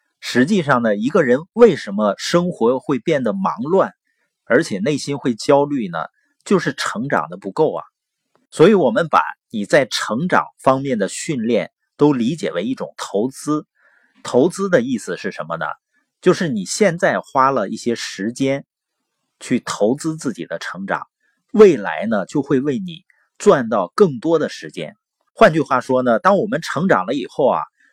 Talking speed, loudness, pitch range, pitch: 240 characters per minute, -18 LUFS, 130-195 Hz, 150 Hz